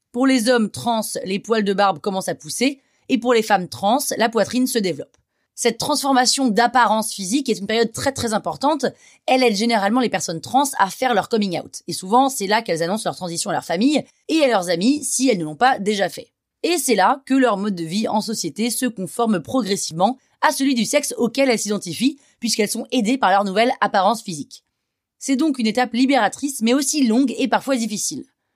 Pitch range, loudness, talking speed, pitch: 200-260 Hz, -19 LUFS, 215 wpm, 230 Hz